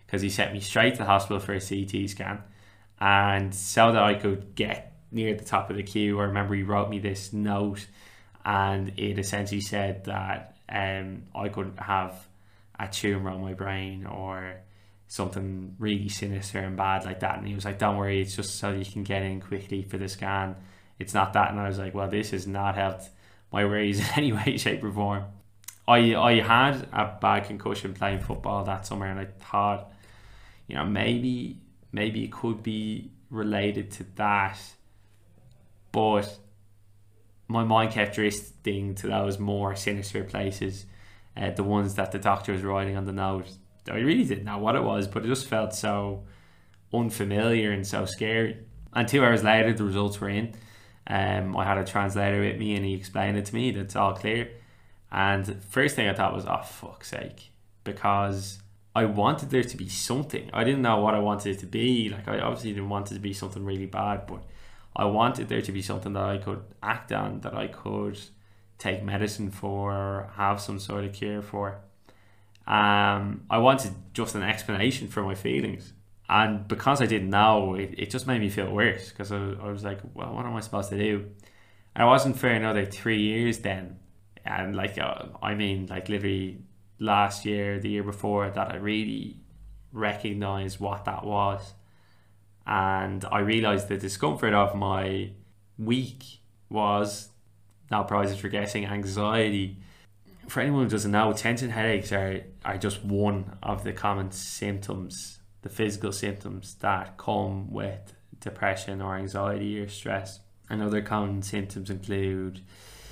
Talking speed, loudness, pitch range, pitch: 180 wpm, -28 LUFS, 95-105 Hz, 100 Hz